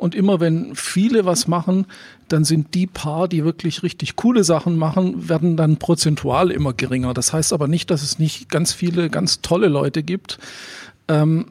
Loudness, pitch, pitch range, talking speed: -19 LUFS, 165 Hz, 155-185 Hz, 185 wpm